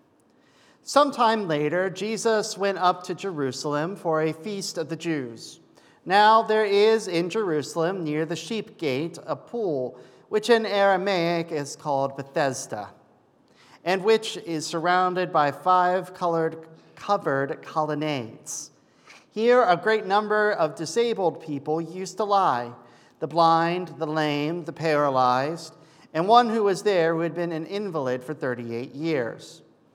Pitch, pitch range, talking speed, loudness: 170 Hz, 155-205 Hz, 140 wpm, -24 LUFS